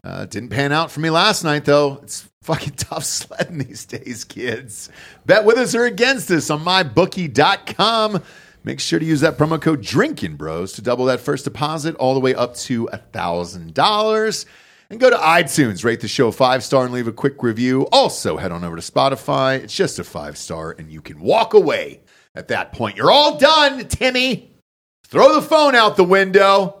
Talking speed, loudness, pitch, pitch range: 190 wpm, -17 LUFS, 150 Hz, 125-200 Hz